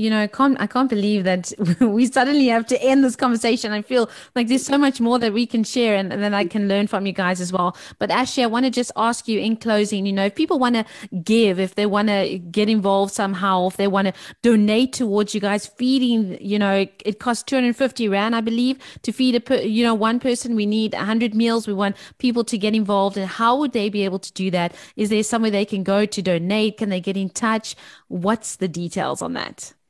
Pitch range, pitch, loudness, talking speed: 200-240 Hz, 215 Hz, -20 LUFS, 245 wpm